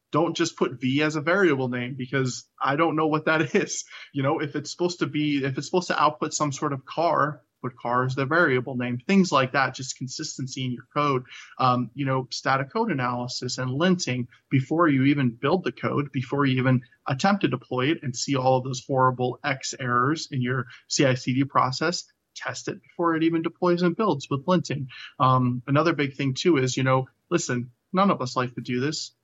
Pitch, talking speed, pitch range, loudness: 135 Hz, 215 wpm, 130-160 Hz, -25 LUFS